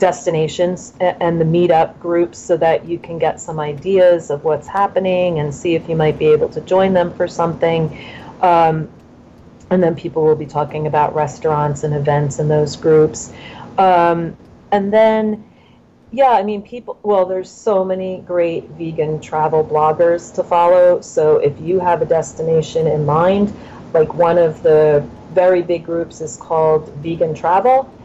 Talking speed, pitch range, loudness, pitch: 165 wpm, 155-185 Hz, -16 LUFS, 170 Hz